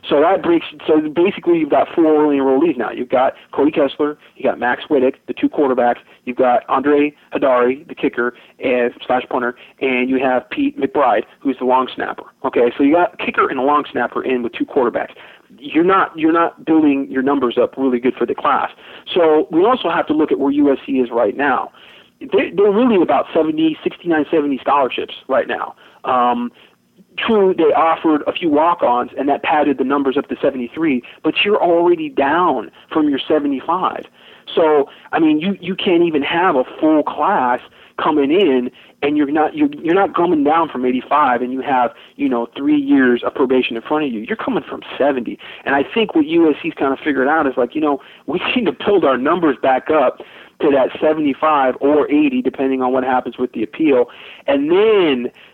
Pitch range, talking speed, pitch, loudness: 130-200 Hz, 205 wpm, 150 Hz, -16 LUFS